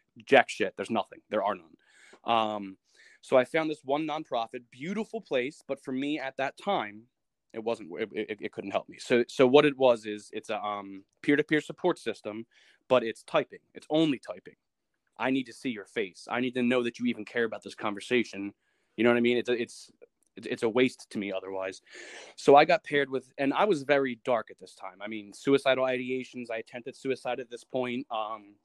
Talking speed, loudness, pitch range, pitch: 220 wpm, -29 LUFS, 115-140 Hz, 125 Hz